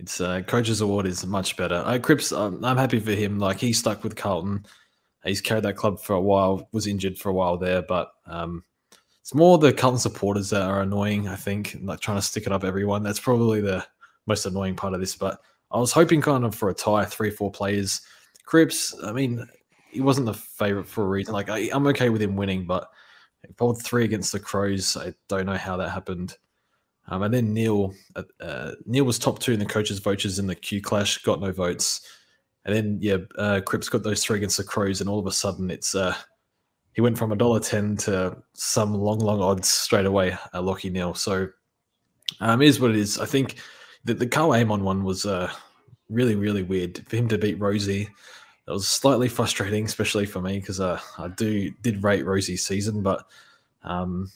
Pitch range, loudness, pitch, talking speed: 95-115 Hz, -24 LUFS, 100 Hz, 215 wpm